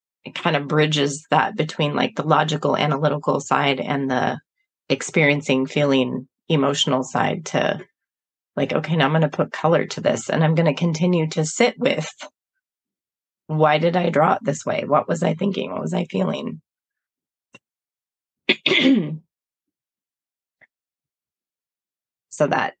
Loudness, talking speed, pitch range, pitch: -20 LUFS, 140 wpm, 145-170 Hz, 155 Hz